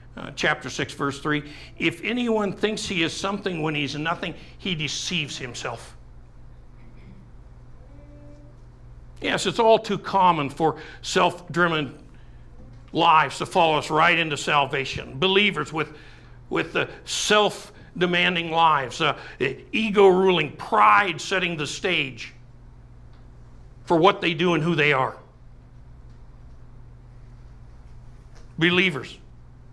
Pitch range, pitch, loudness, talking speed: 120-180 Hz, 150 Hz, -22 LUFS, 105 wpm